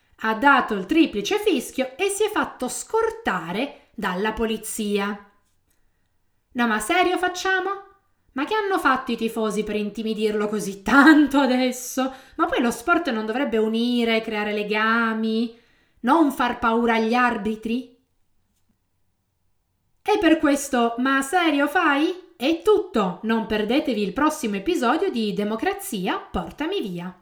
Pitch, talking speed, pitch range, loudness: 235 Hz, 130 wpm, 215-300 Hz, -22 LUFS